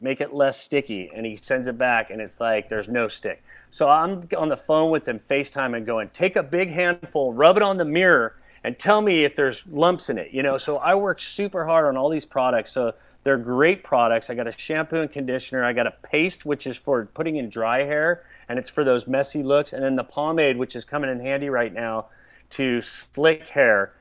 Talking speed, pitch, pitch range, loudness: 235 wpm, 140 Hz, 120-160 Hz, -22 LUFS